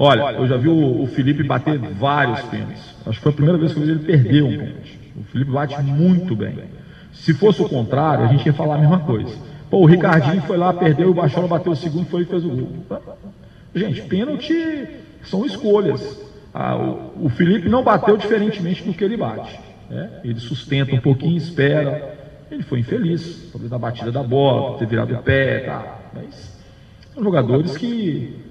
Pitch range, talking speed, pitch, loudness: 130-175 Hz, 190 wpm, 150 Hz, -18 LUFS